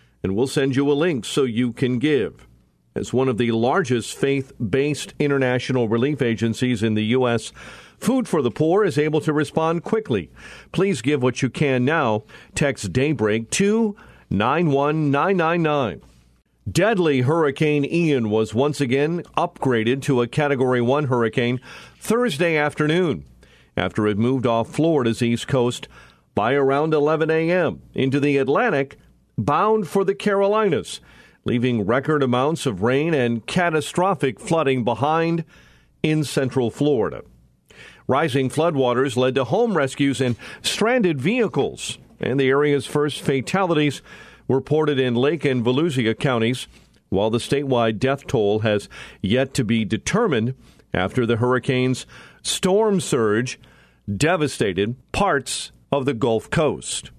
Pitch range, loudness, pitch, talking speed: 120-155 Hz, -21 LUFS, 135 Hz, 135 wpm